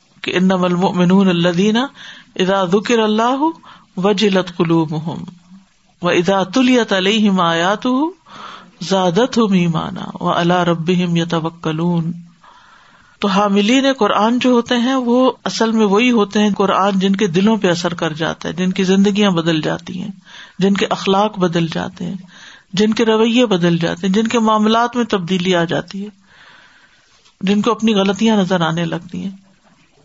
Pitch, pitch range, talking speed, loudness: 195 Hz, 180-215 Hz, 150 wpm, -15 LUFS